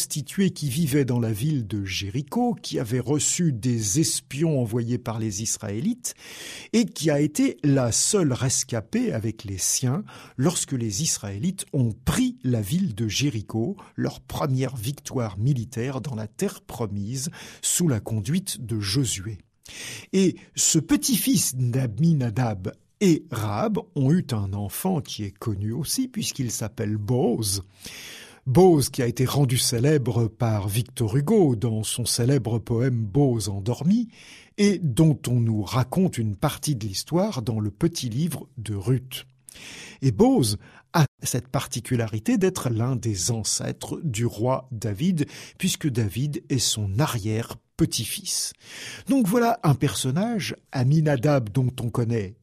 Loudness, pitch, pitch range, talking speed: -24 LUFS, 130 Hz, 115-155 Hz, 140 wpm